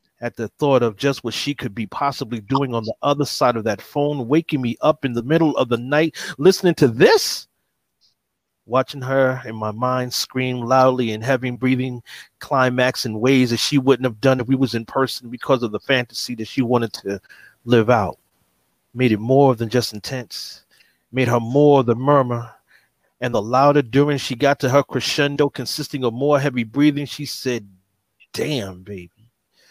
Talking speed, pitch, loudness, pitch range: 190 wpm, 130 Hz, -19 LUFS, 120-140 Hz